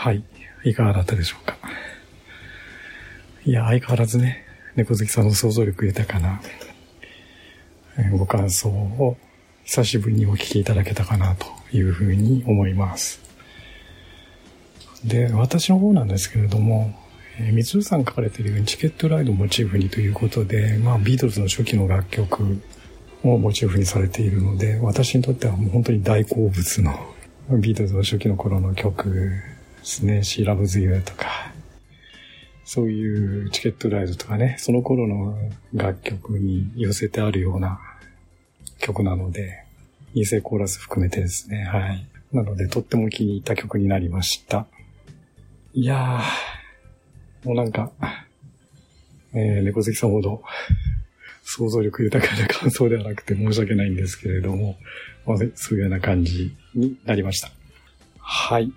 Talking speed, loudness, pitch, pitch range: 305 characters per minute, -22 LUFS, 105 Hz, 95-115 Hz